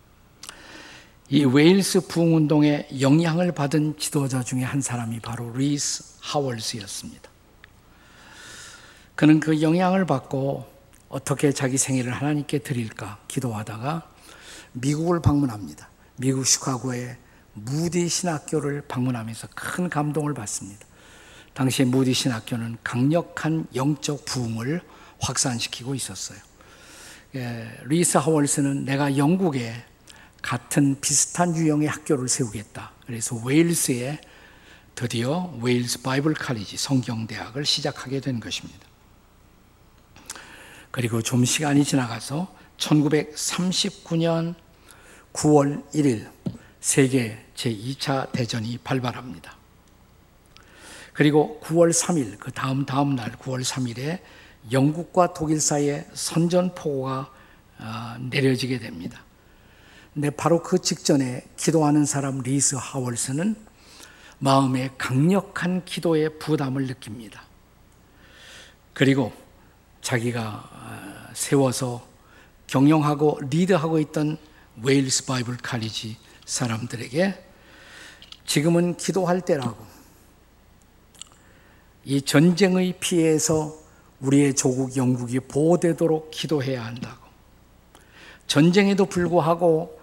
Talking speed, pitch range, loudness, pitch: 235 characters per minute, 125-155 Hz, -23 LUFS, 135 Hz